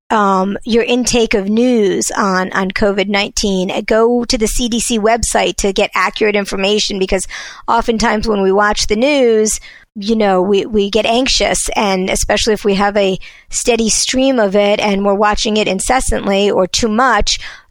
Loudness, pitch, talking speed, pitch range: -13 LUFS, 210 Hz, 165 wpm, 200-230 Hz